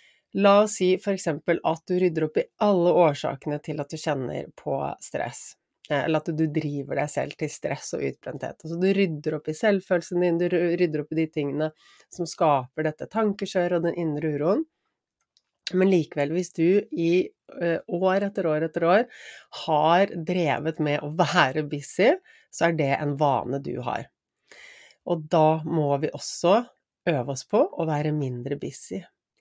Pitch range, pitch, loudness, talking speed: 150-180 Hz, 165 Hz, -25 LUFS, 170 wpm